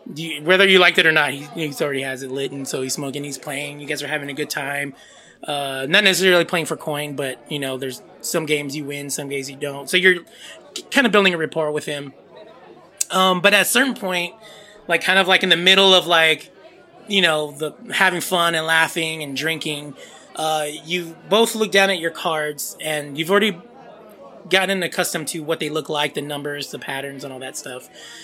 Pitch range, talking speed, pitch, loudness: 145-185 Hz, 220 wpm, 160 Hz, -19 LUFS